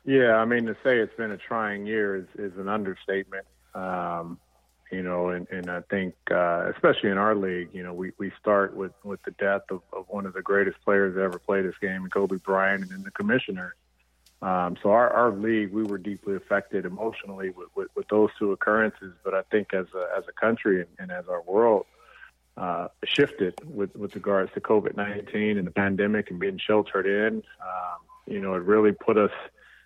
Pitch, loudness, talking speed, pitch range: 100 Hz, -26 LUFS, 205 wpm, 95-105 Hz